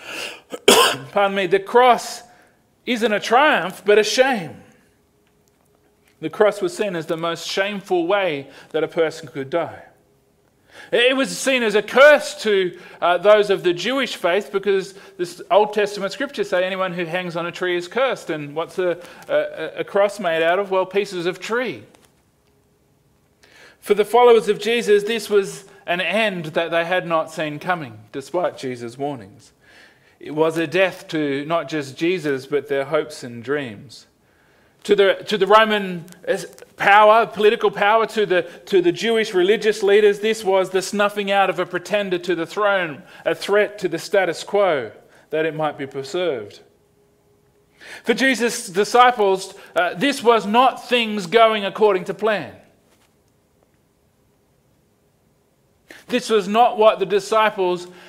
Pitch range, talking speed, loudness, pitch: 170-220 Hz, 155 wpm, -19 LUFS, 195 Hz